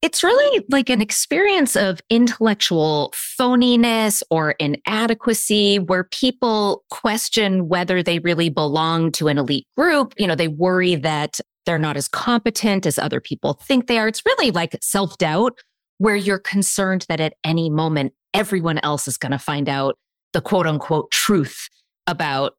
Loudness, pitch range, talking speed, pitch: -19 LUFS, 160-230 Hz, 155 wpm, 190 Hz